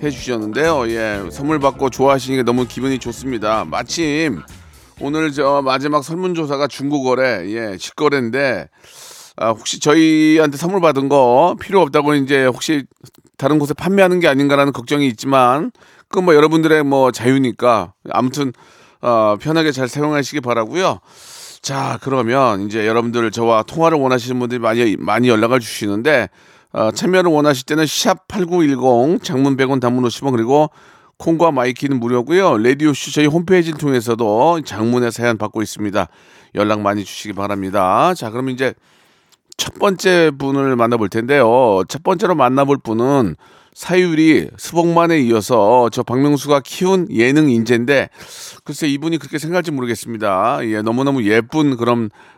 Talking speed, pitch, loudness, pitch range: 335 characters per minute, 135 Hz, -15 LUFS, 120-150 Hz